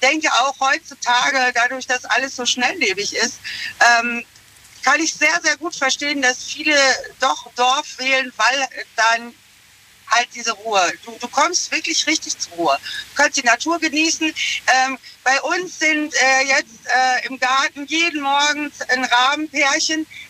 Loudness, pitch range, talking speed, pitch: -17 LUFS, 250-310 Hz, 150 wpm, 275 Hz